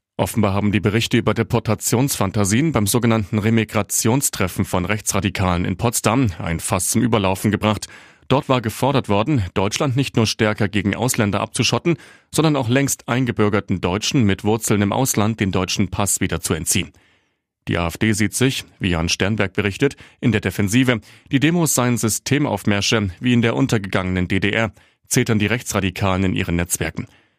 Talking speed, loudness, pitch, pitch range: 155 wpm, -19 LUFS, 110 Hz, 100-120 Hz